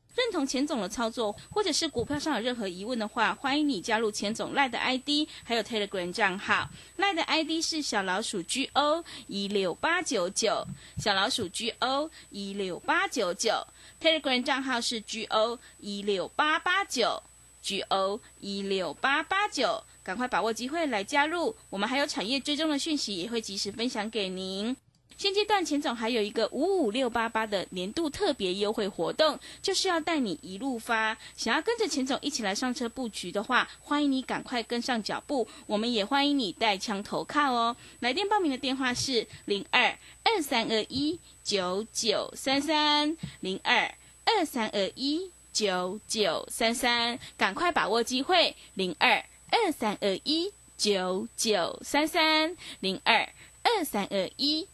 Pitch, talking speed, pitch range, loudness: 250 Hz, 260 characters per minute, 210-300 Hz, -28 LUFS